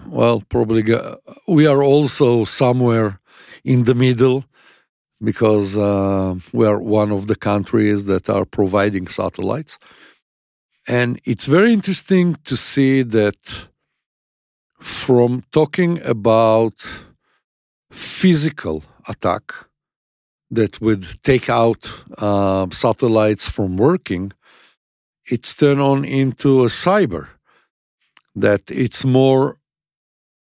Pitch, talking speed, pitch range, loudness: 115 Hz, 100 wpm, 100-135 Hz, -16 LUFS